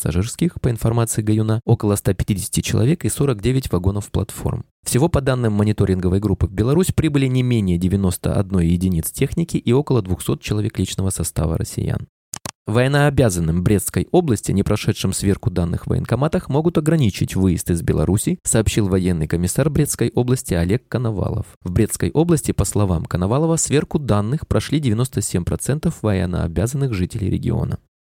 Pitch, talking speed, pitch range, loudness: 110 Hz, 135 wpm, 95-135 Hz, -19 LUFS